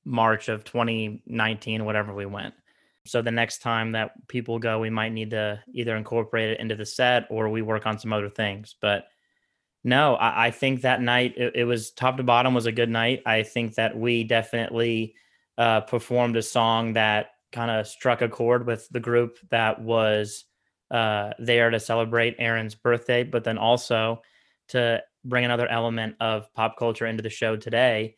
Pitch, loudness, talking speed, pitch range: 115 Hz, -24 LUFS, 185 wpm, 110-120 Hz